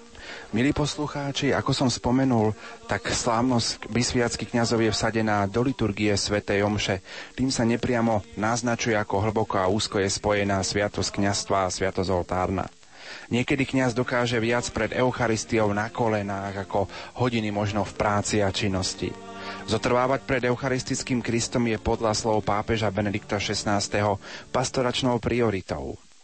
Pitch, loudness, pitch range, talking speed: 110 Hz, -25 LUFS, 100-120 Hz, 130 wpm